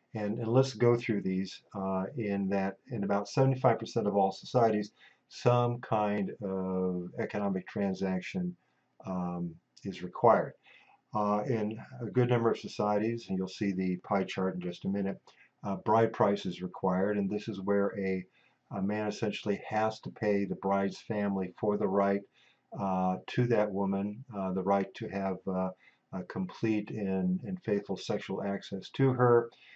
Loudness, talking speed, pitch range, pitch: -32 LUFS, 165 wpm, 95-110 Hz, 100 Hz